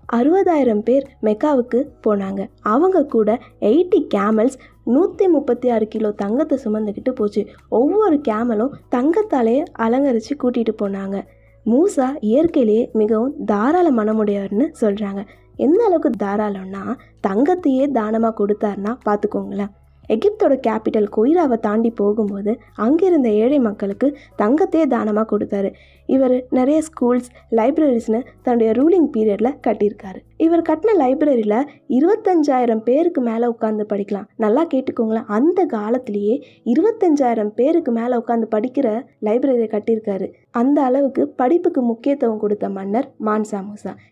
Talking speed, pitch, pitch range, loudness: 110 wpm, 235 Hz, 215-280 Hz, -18 LUFS